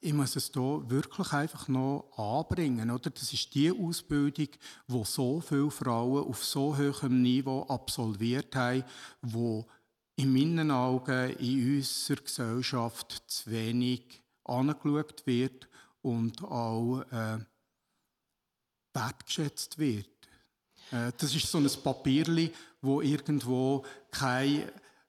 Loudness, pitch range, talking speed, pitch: -32 LUFS, 120-145 Hz, 115 wpm, 130 Hz